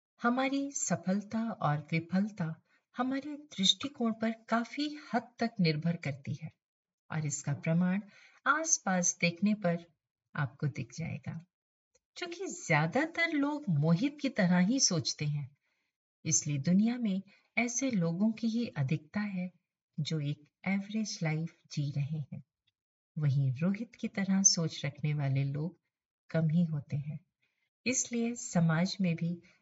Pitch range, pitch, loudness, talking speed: 155-225 Hz, 175 Hz, -32 LUFS, 130 wpm